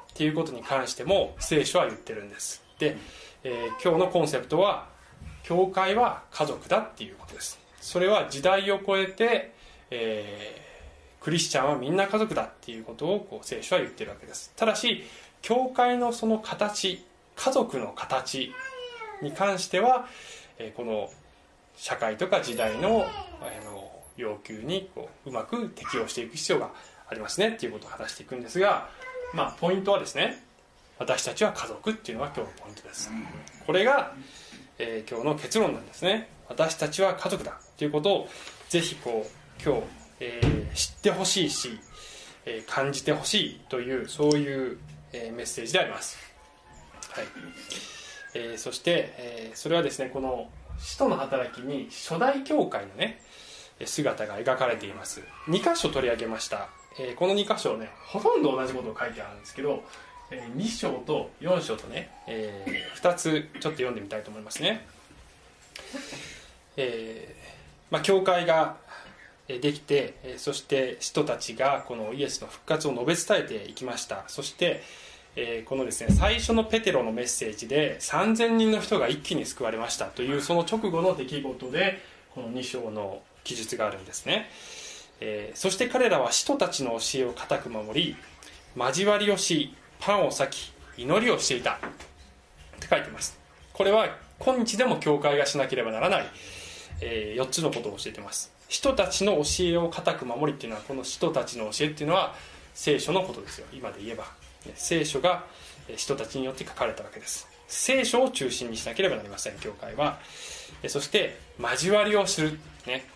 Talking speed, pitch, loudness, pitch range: 330 characters per minute, 160 Hz, -28 LUFS, 130-200 Hz